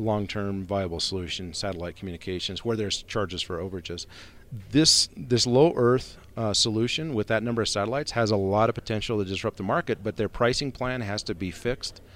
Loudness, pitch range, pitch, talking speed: -26 LUFS, 95-120 Hz, 105 Hz, 190 wpm